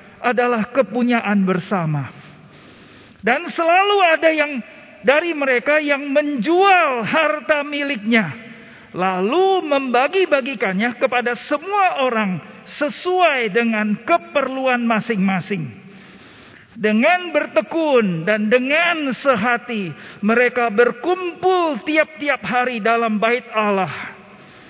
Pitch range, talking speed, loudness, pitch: 225-305 Hz, 85 wpm, -18 LUFS, 250 Hz